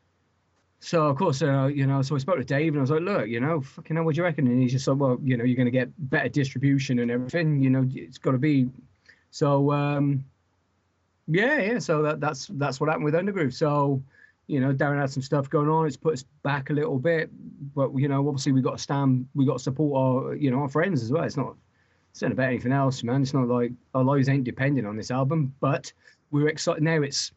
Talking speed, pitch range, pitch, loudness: 245 wpm, 130-155 Hz, 140 Hz, -25 LUFS